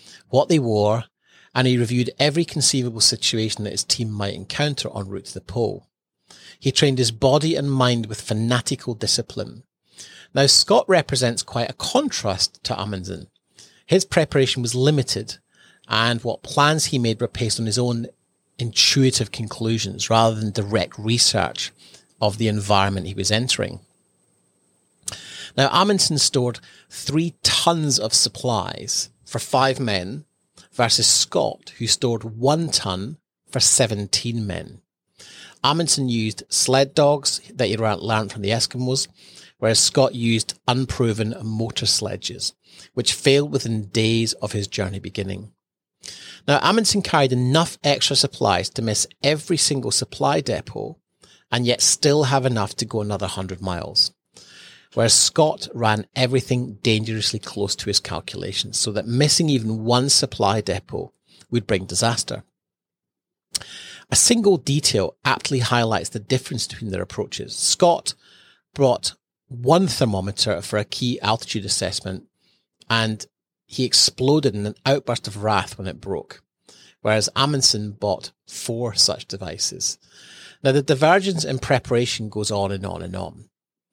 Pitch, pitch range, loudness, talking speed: 115 Hz, 105-135 Hz, -20 LUFS, 140 wpm